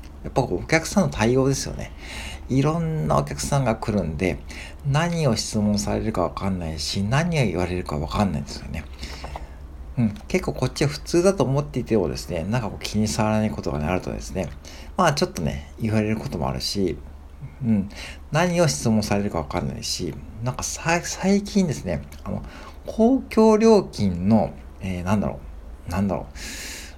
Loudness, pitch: -23 LUFS, 95 Hz